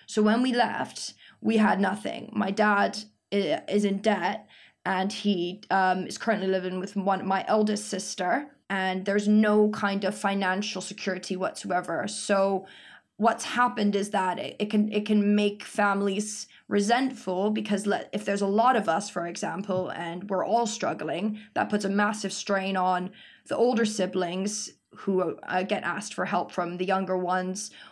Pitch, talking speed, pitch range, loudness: 200 Hz, 165 wpm, 190-210 Hz, -27 LUFS